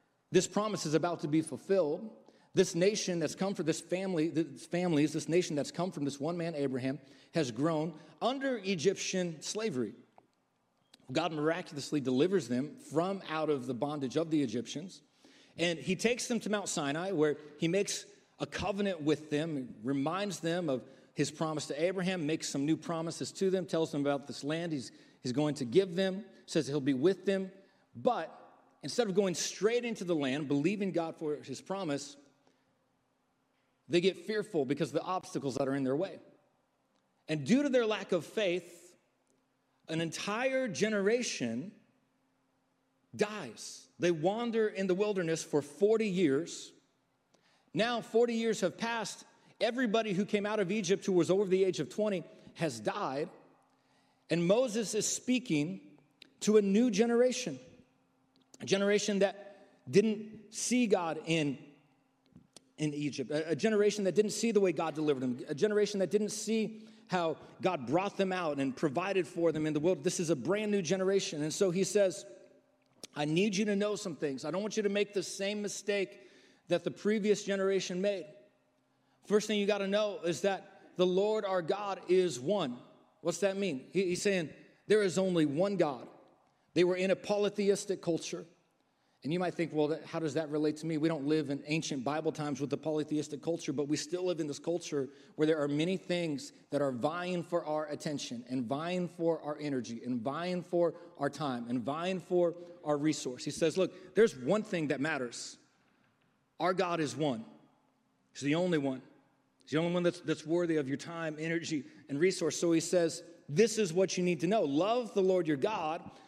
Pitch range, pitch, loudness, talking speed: 150-200 Hz, 175 Hz, -33 LUFS, 185 wpm